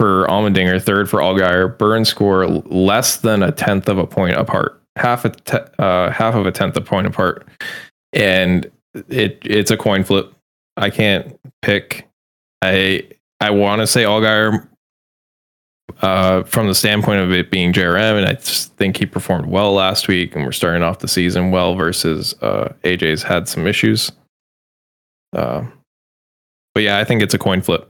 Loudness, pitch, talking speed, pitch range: -16 LUFS, 95 Hz, 175 wpm, 90-105 Hz